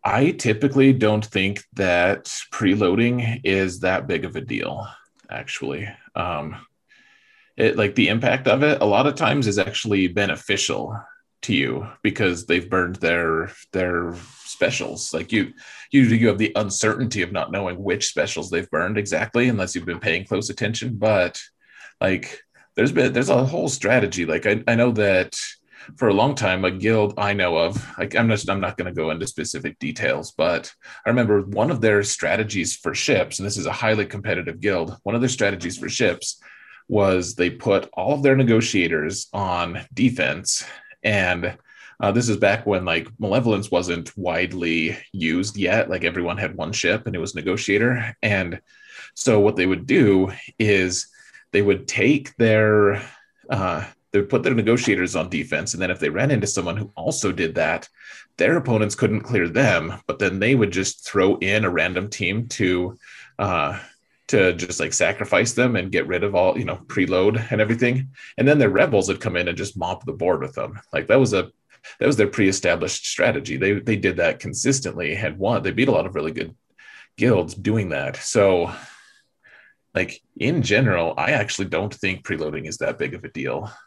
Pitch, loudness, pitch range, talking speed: 105 Hz, -21 LUFS, 95-115 Hz, 185 wpm